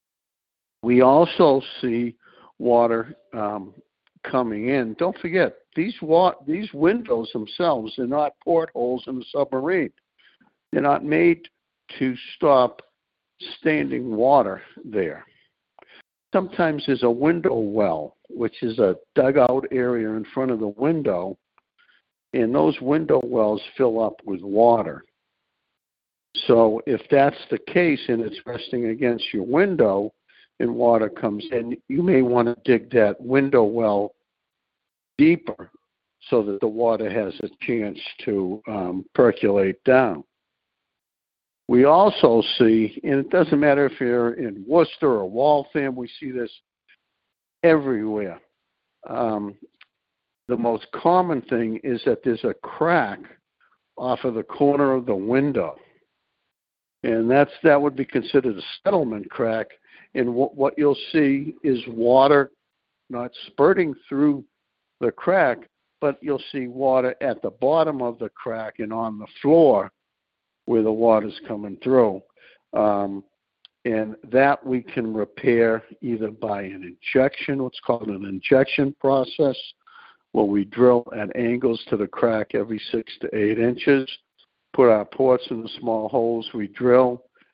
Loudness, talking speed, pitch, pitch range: -21 LUFS, 135 wpm, 125 Hz, 110-140 Hz